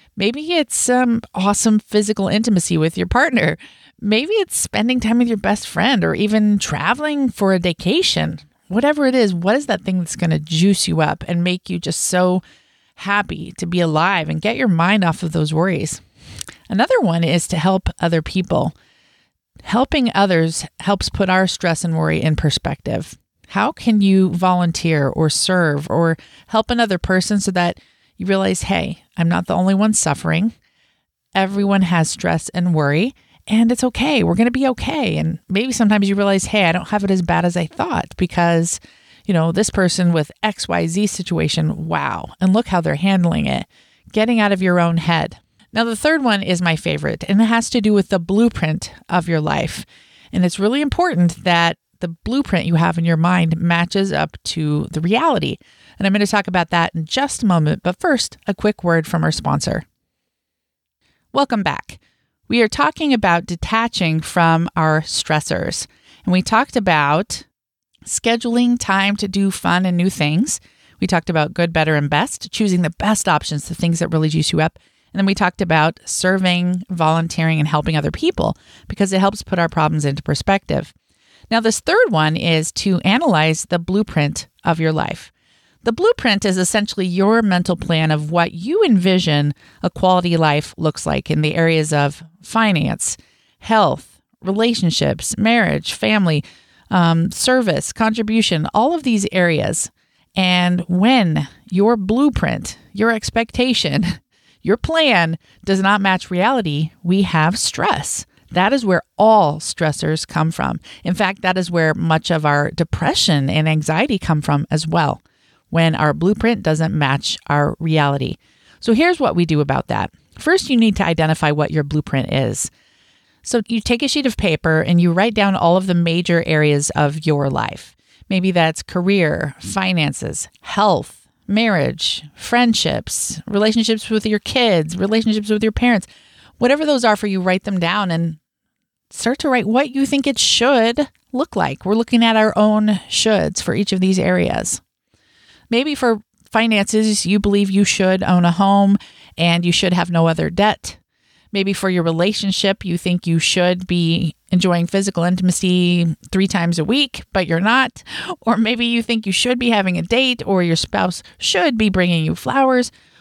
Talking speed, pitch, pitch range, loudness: 175 wpm, 185 Hz, 165-215 Hz, -17 LUFS